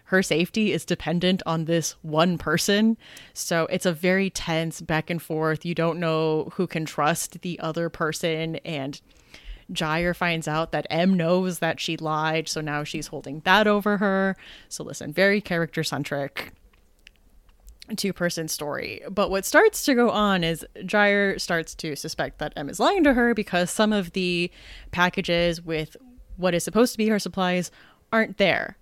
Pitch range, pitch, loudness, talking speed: 160-195 Hz, 170 Hz, -24 LUFS, 170 wpm